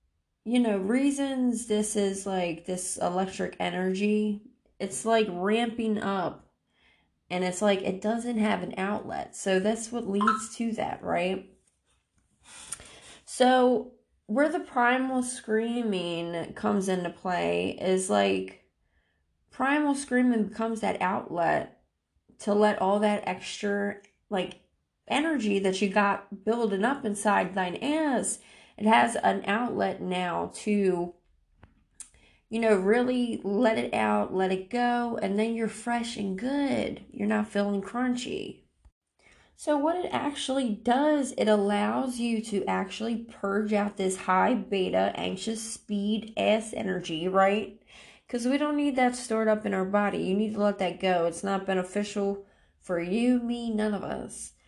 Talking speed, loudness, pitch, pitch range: 140 wpm, -28 LUFS, 210 Hz, 190-235 Hz